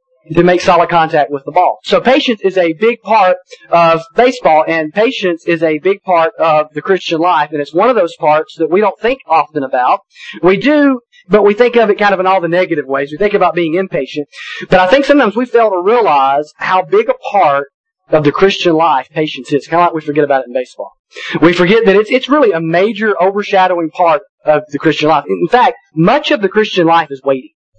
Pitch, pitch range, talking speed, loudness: 180 Hz, 155-215 Hz, 230 wpm, -11 LUFS